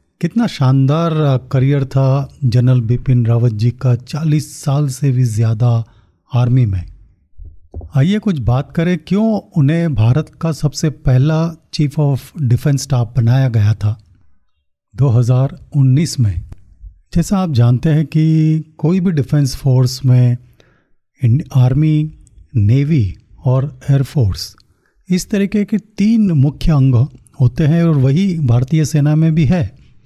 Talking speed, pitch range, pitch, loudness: 130 wpm, 120-155 Hz, 135 Hz, -15 LUFS